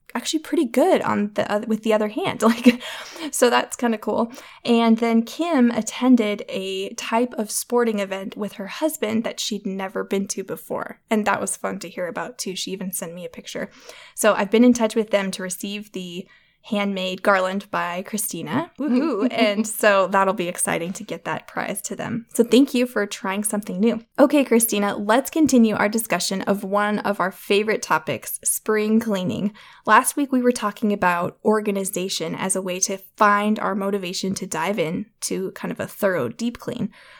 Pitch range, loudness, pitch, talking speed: 195-235 Hz, -22 LUFS, 215 Hz, 190 wpm